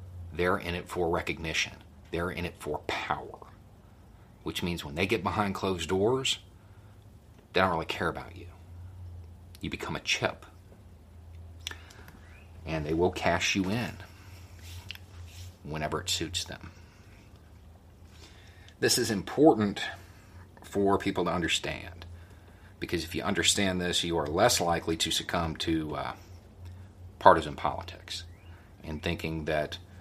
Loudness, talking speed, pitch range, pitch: -29 LUFS, 125 wpm, 85-95 Hz, 90 Hz